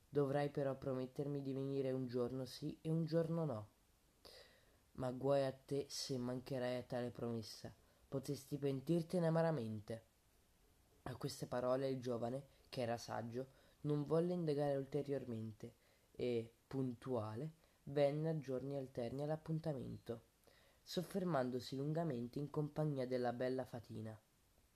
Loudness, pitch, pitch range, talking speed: -43 LUFS, 135 Hz, 120-145 Hz, 120 wpm